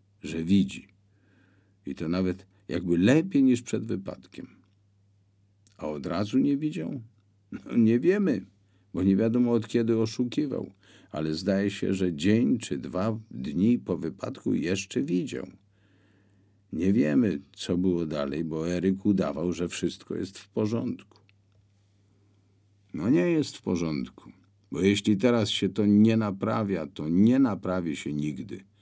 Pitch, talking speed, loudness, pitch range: 100 Hz, 135 wpm, -27 LUFS, 95-105 Hz